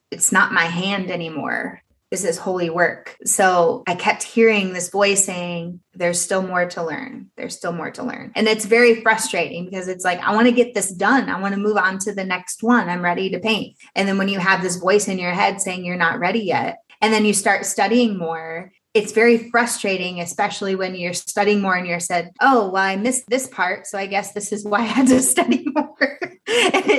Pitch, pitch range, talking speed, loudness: 200 Hz, 180-225 Hz, 225 wpm, -19 LUFS